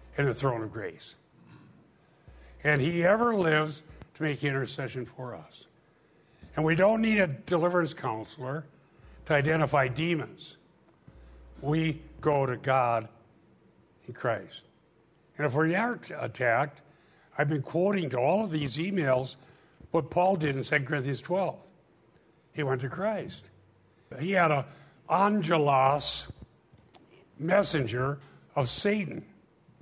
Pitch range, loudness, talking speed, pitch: 130-170 Hz, -28 LUFS, 125 wpm, 150 Hz